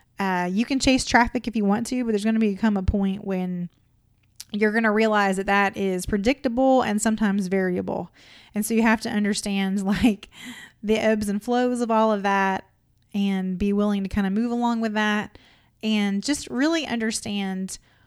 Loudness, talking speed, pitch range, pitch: -23 LUFS, 190 wpm, 195-225 Hz, 210 Hz